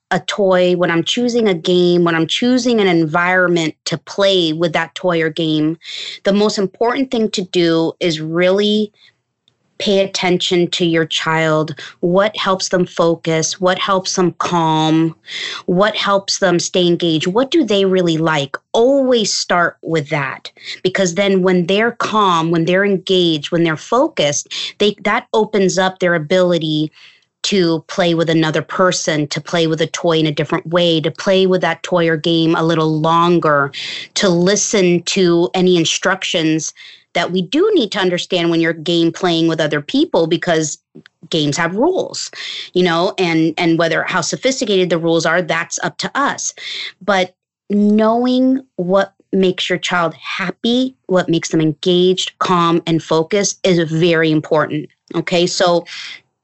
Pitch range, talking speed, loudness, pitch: 165-195 Hz, 160 wpm, -15 LUFS, 180 Hz